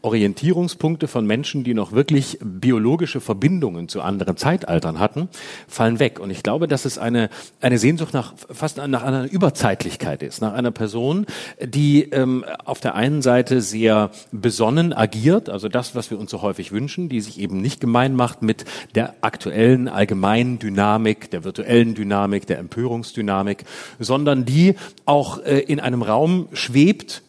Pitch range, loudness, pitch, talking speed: 110-145 Hz, -20 LUFS, 125 Hz, 160 wpm